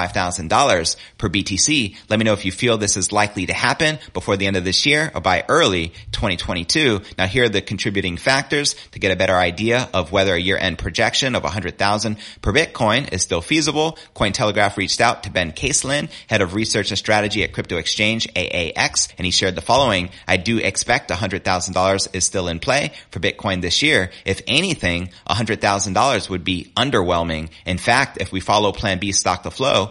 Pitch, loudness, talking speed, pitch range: 100 Hz, -18 LUFS, 215 wpm, 95-110 Hz